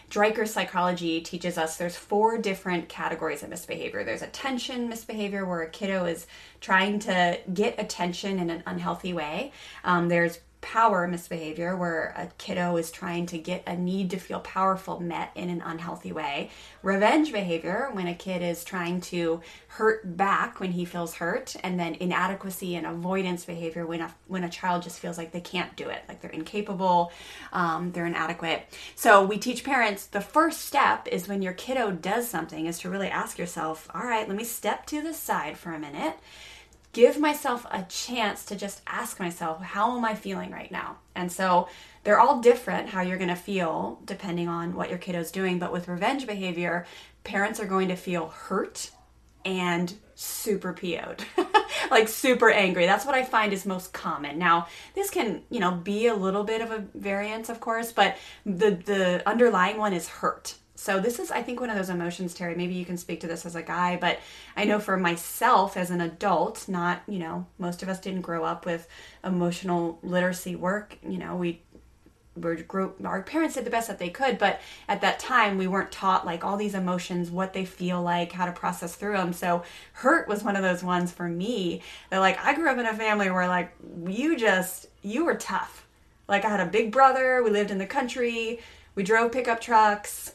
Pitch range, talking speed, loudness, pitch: 175-210 Hz, 200 wpm, -27 LUFS, 185 Hz